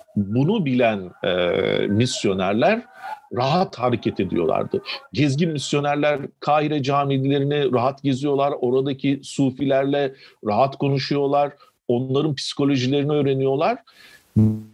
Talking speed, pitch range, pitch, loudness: 80 wpm, 130-145 Hz, 140 Hz, -21 LUFS